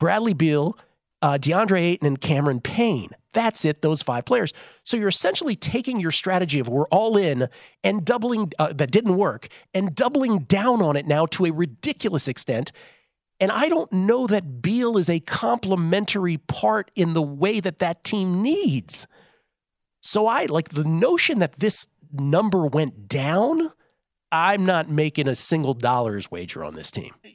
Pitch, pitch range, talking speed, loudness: 180 Hz, 150-210 Hz, 165 wpm, -22 LUFS